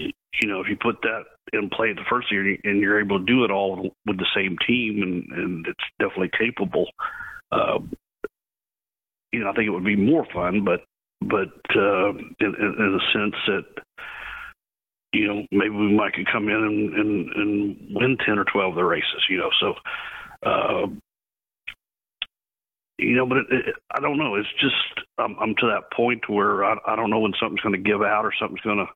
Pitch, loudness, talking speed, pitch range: 105 Hz, -23 LUFS, 205 wpm, 100-115 Hz